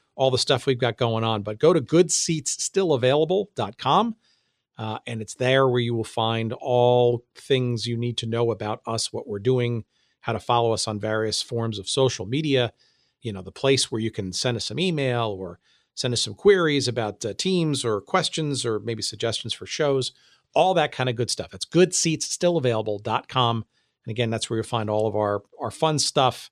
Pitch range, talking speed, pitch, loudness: 110-135 Hz, 195 wpm, 120 Hz, -23 LUFS